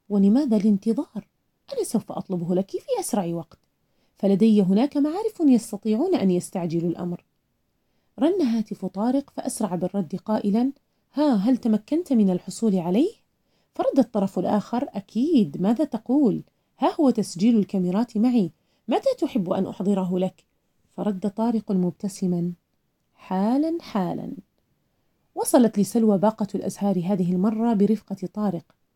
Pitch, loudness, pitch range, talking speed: 210 Hz, -23 LUFS, 190-245 Hz, 120 wpm